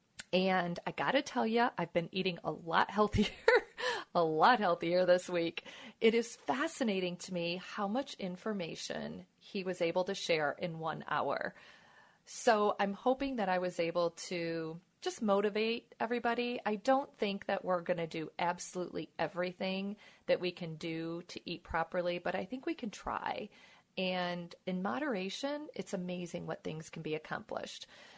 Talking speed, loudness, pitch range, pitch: 160 wpm, -35 LUFS, 175-225 Hz, 185 Hz